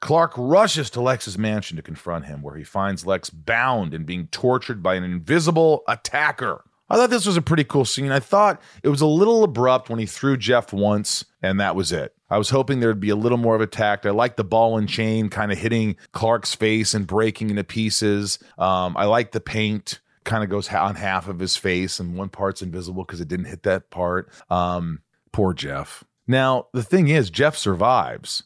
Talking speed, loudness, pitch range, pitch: 215 wpm, -21 LUFS, 95-130 Hz, 110 Hz